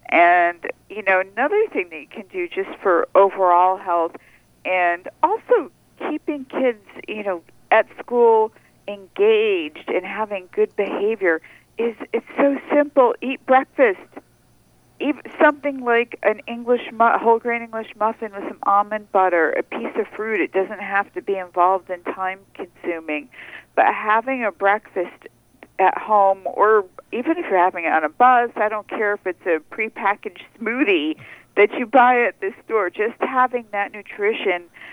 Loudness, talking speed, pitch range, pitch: -20 LUFS, 160 wpm, 195-290 Hz, 220 Hz